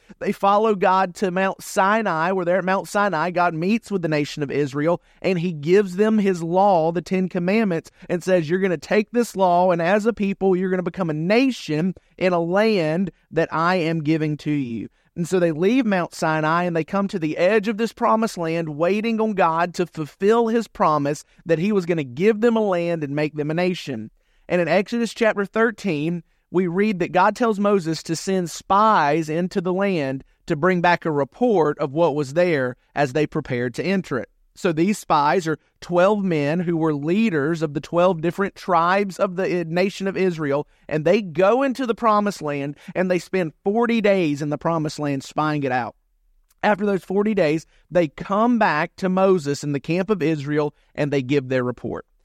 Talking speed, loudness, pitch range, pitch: 205 wpm, -21 LUFS, 155-200 Hz, 180 Hz